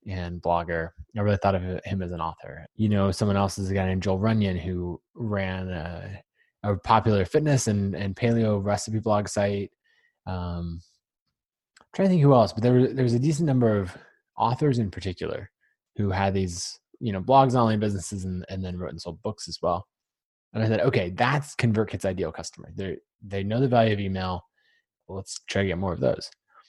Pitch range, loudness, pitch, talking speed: 95-115 Hz, -26 LUFS, 100 Hz, 205 wpm